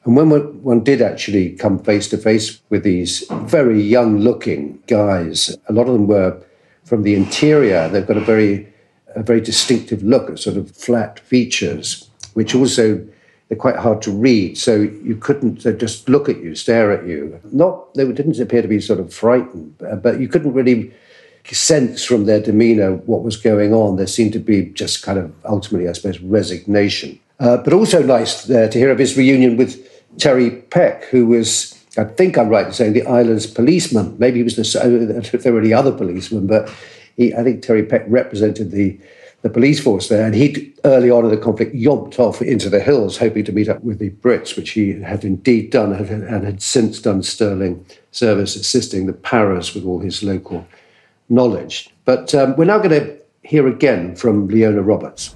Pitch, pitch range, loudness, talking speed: 110 Hz, 105-125 Hz, -15 LUFS, 195 wpm